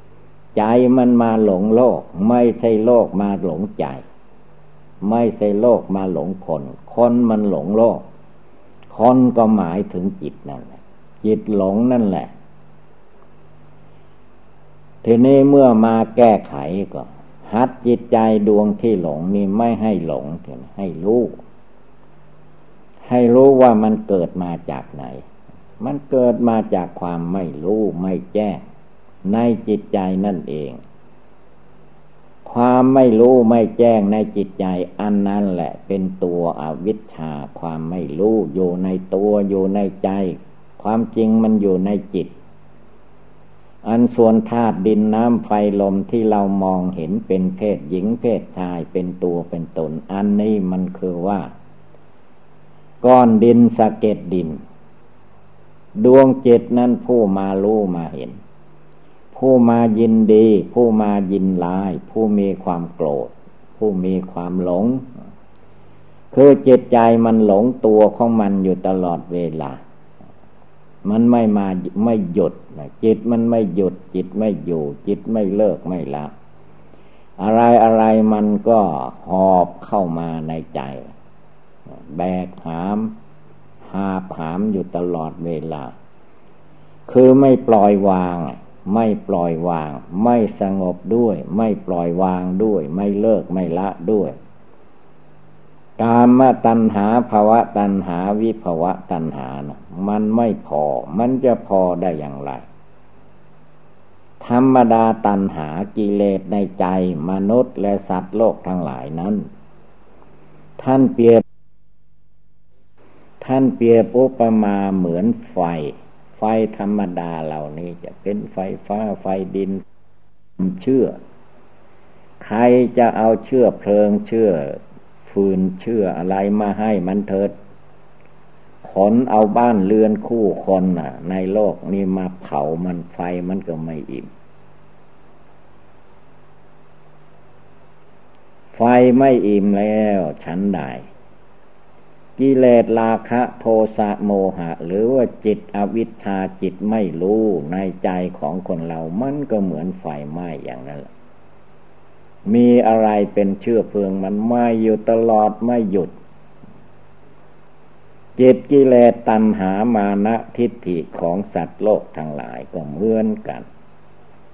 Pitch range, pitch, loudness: 90-115 Hz, 100 Hz, -17 LUFS